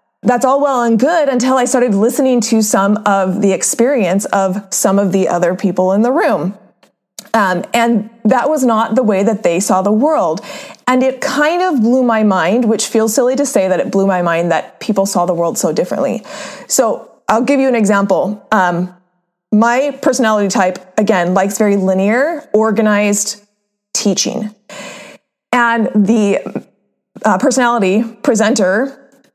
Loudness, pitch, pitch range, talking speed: -13 LUFS, 220 Hz, 195-250 Hz, 165 wpm